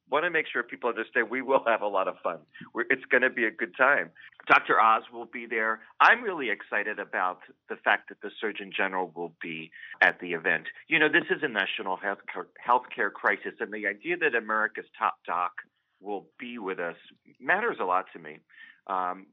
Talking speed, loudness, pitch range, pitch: 205 wpm, -27 LUFS, 85-110 Hz, 95 Hz